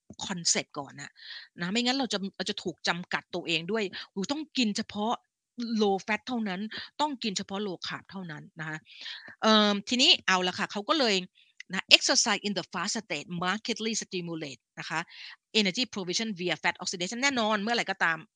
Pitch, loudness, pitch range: 205 Hz, -28 LUFS, 180-225 Hz